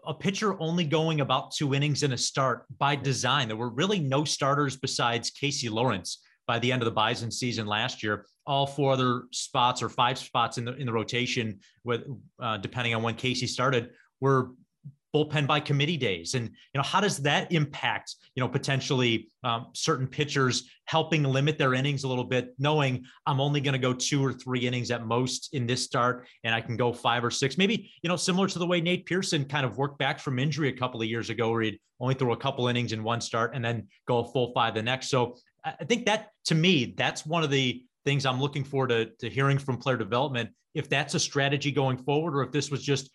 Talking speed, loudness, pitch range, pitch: 230 wpm, -28 LUFS, 120-145 Hz, 130 Hz